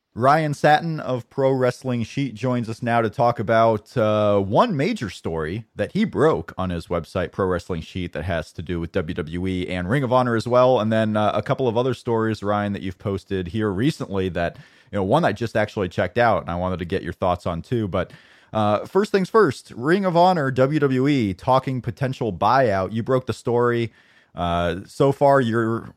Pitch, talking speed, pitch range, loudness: 115 Hz, 205 wpm, 95-130 Hz, -22 LUFS